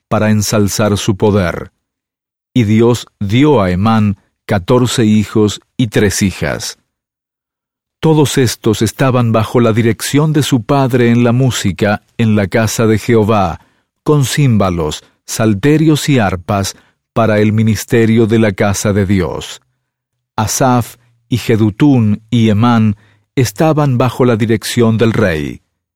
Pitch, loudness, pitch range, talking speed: 115 Hz, -12 LUFS, 105-125 Hz, 130 wpm